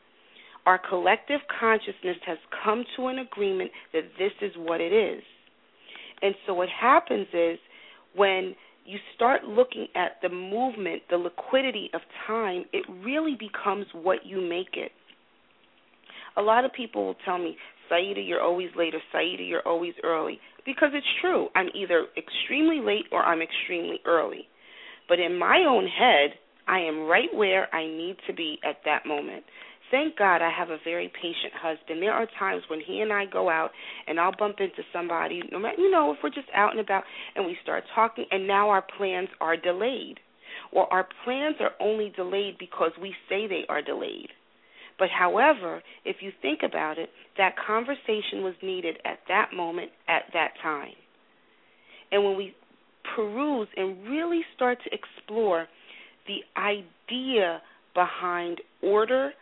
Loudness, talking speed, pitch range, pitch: -27 LUFS, 165 wpm, 175-255 Hz, 200 Hz